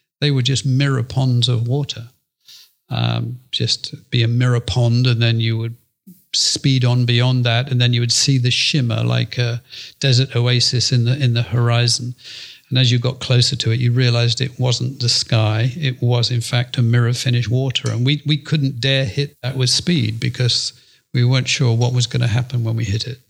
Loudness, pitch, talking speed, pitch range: -17 LUFS, 125 Hz, 205 wpm, 120-130 Hz